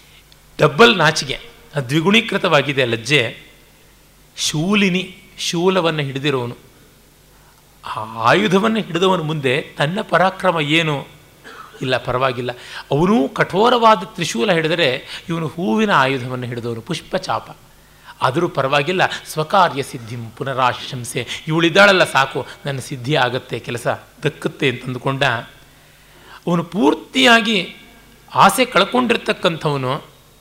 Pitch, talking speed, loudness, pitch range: 155 Hz, 85 wpm, -17 LUFS, 135-190 Hz